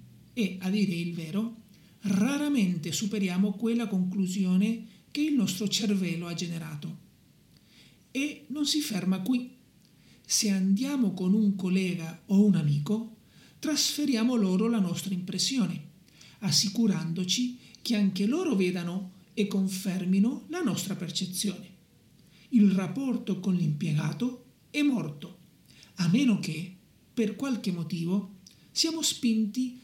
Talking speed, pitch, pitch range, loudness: 115 wpm, 195 Hz, 185-230 Hz, -28 LUFS